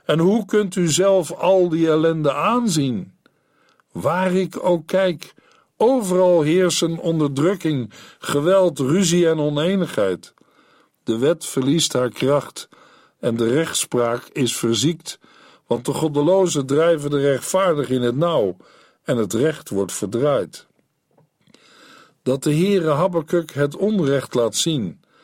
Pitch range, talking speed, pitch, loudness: 140-185 Hz, 125 wpm, 160 Hz, -19 LUFS